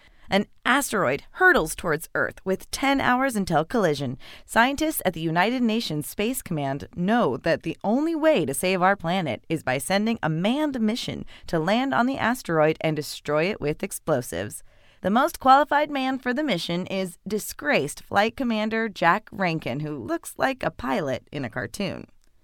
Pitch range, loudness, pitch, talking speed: 165-250 Hz, -24 LUFS, 200 Hz, 170 wpm